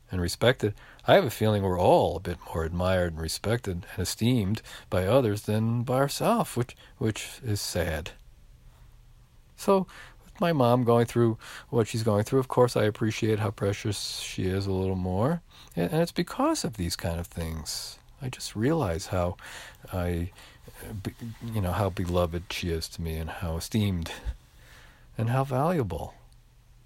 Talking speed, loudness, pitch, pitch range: 165 wpm, -28 LUFS, 110 Hz, 90-120 Hz